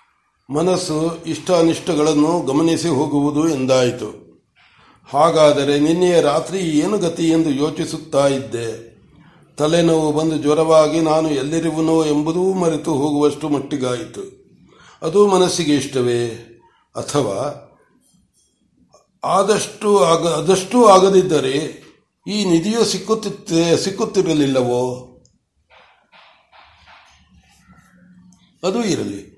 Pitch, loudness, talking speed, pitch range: 160 Hz, -17 LUFS, 70 wpm, 145-180 Hz